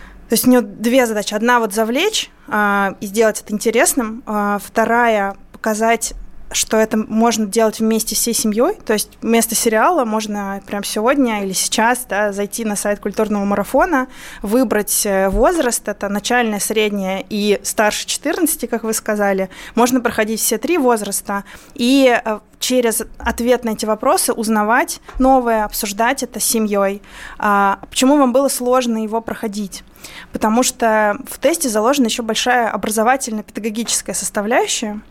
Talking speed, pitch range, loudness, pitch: 145 wpm, 210-245 Hz, -16 LUFS, 225 Hz